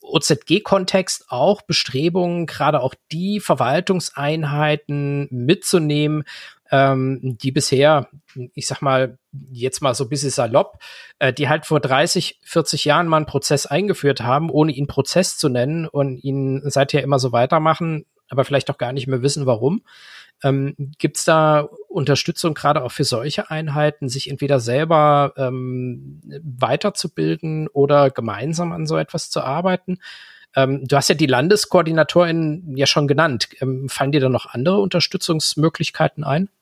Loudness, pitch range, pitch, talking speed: -19 LUFS, 135-165 Hz, 145 Hz, 145 wpm